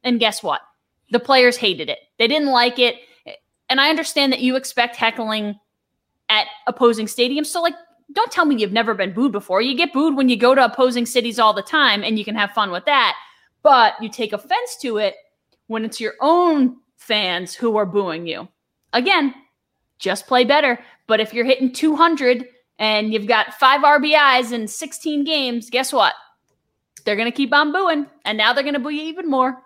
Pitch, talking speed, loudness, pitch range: 250 Hz, 195 wpm, -18 LUFS, 220-290 Hz